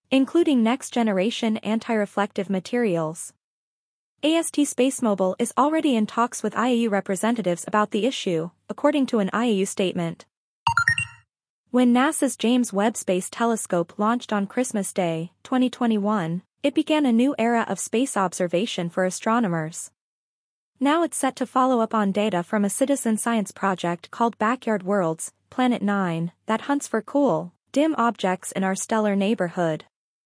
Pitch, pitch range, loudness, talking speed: 220 Hz, 190-250 Hz, -23 LUFS, 140 wpm